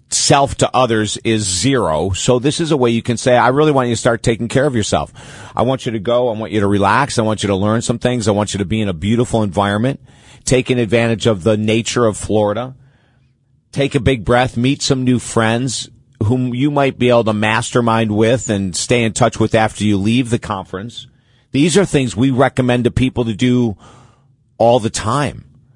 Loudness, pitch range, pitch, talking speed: -15 LUFS, 110-130 Hz, 120 Hz, 220 wpm